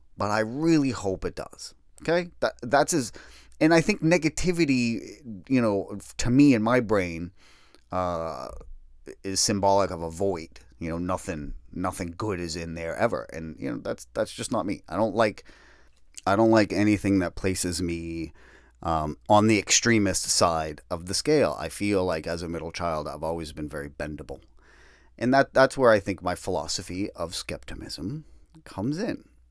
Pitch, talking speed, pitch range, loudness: 95 Hz, 175 wpm, 80-110 Hz, -26 LUFS